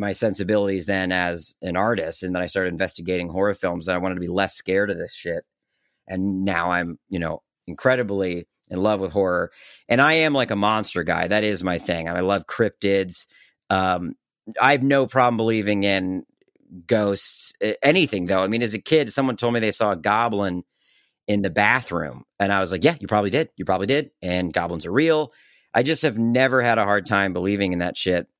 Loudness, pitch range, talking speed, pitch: -22 LUFS, 90-110 Hz, 210 wpm, 100 Hz